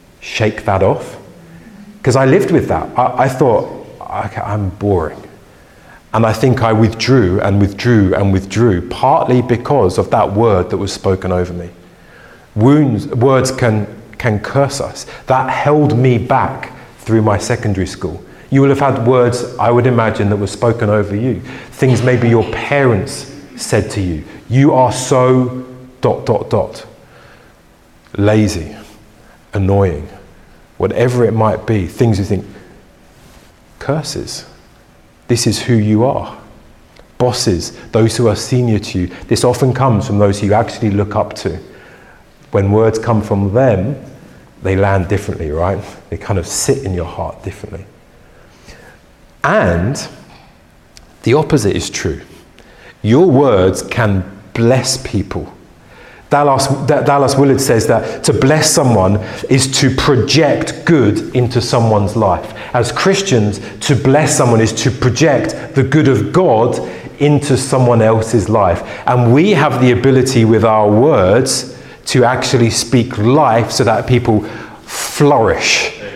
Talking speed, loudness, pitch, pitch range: 140 wpm, -13 LUFS, 115 Hz, 100-130 Hz